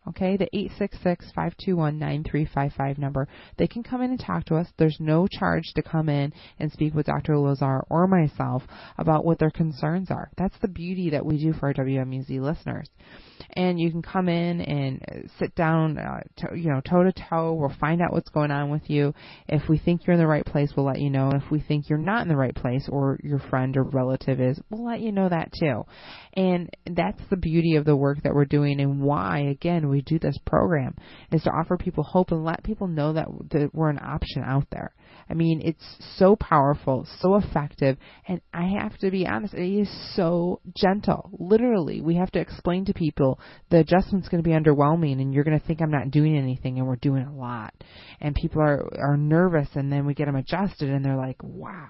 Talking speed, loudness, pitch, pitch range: 225 wpm, -25 LUFS, 155 Hz, 140-175 Hz